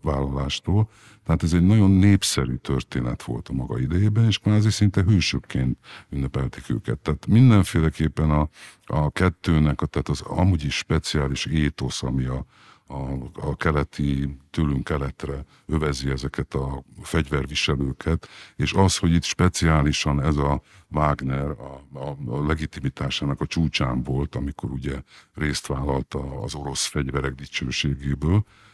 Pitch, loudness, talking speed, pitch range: 75 Hz, -23 LUFS, 135 wpm, 70-90 Hz